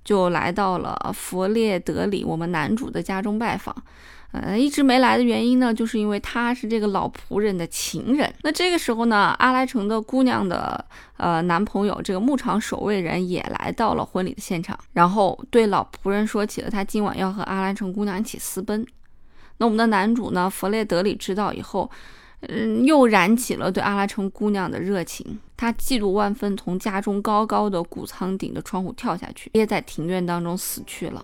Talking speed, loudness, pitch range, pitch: 295 characters per minute, -22 LUFS, 190-230 Hz, 205 Hz